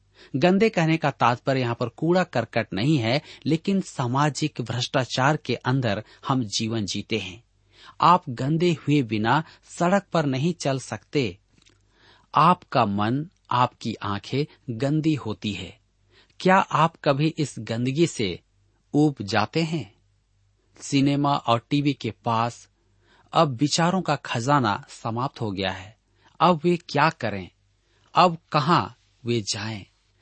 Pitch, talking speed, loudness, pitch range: 125 Hz, 130 wpm, -24 LUFS, 105-150 Hz